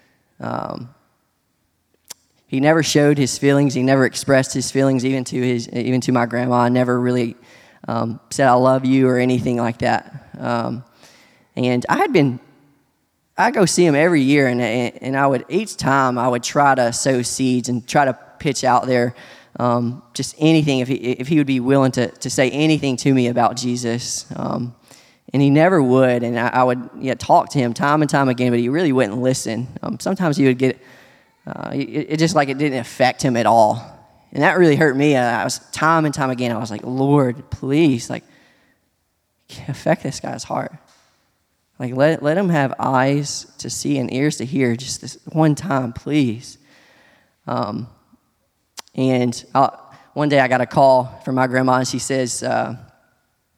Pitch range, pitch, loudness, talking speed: 125-140 Hz, 130 Hz, -18 LUFS, 190 wpm